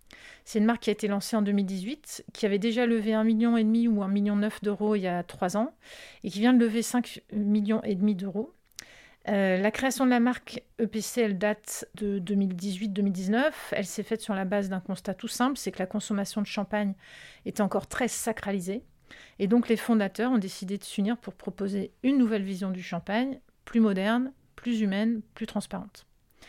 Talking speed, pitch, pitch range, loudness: 190 wpm, 210 Hz, 200-230 Hz, -28 LUFS